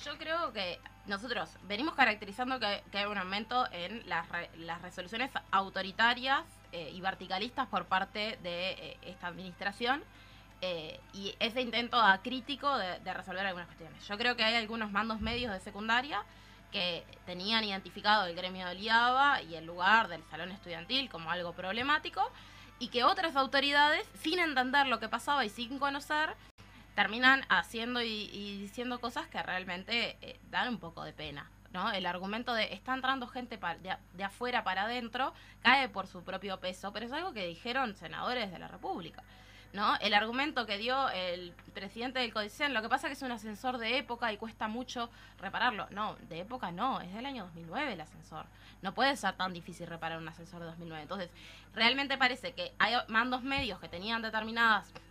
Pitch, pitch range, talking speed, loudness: 220 Hz, 185-255 Hz, 180 wpm, -33 LUFS